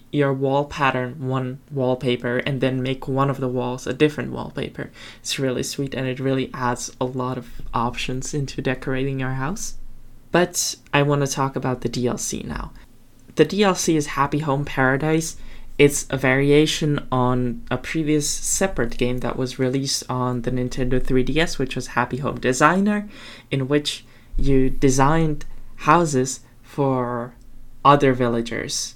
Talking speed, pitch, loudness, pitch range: 150 wpm, 130 Hz, -22 LUFS, 125-140 Hz